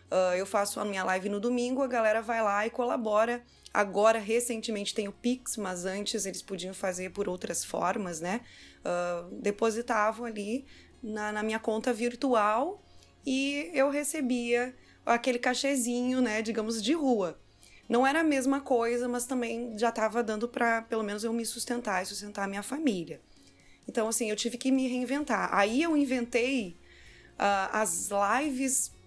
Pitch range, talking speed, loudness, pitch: 205-250 Hz, 160 wpm, -30 LUFS, 225 Hz